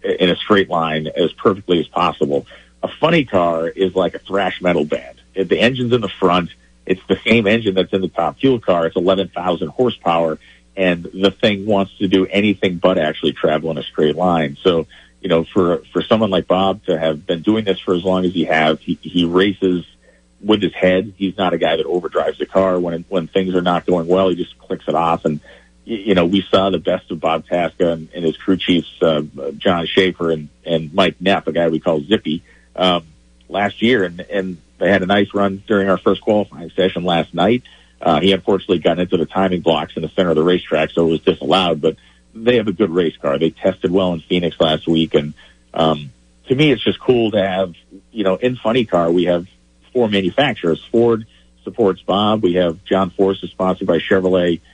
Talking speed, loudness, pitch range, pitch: 220 wpm, -17 LUFS, 80-95 Hz, 90 Hz